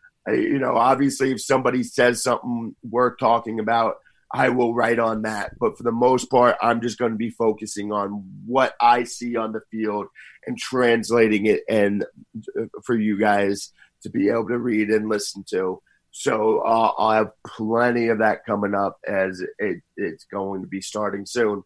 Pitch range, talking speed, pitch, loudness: 105-120 Hz, 185 wpm, 115 Hz, -22 LUFS